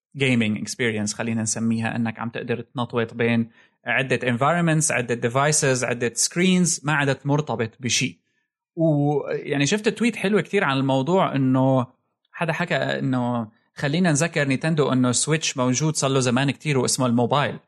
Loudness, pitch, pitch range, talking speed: -22 LUFS, 135 Hz, 120-160 Hz, 145 wpm